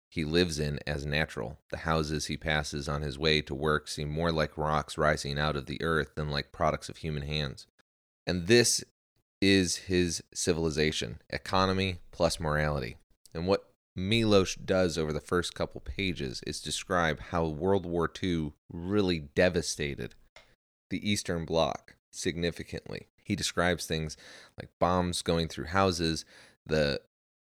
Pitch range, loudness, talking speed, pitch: 75-90 Hz, -30 LUFS, 145 wpm, 80 Hz